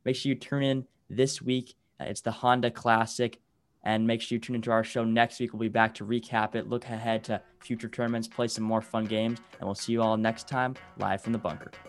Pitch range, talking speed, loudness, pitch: 110-120 Hz, 240 wpm, -29 LUFS, 115 Hz